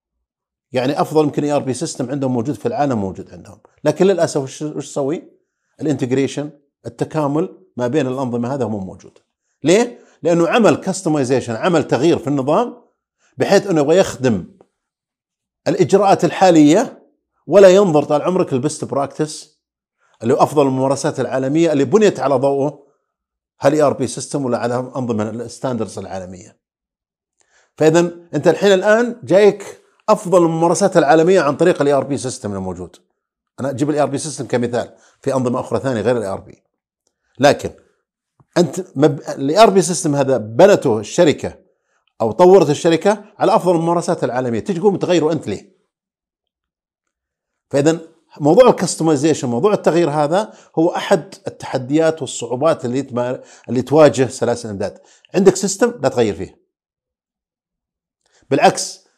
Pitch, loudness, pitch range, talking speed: 150 Hz, -16 LUFS, 130-175 Hz, 135 wpm